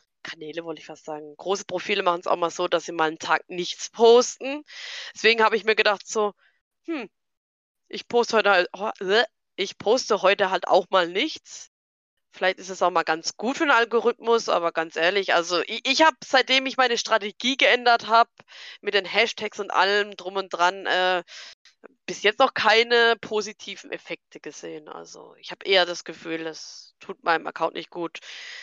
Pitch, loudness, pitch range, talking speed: 205 Hz, -22 LUFS, 180-235 Hz, 185 wpm